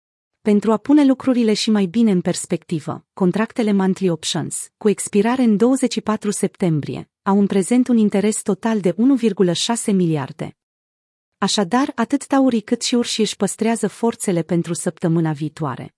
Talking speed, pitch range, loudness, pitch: 140 wpm, 175-230 Hz, -19 LUFS, 205 Hz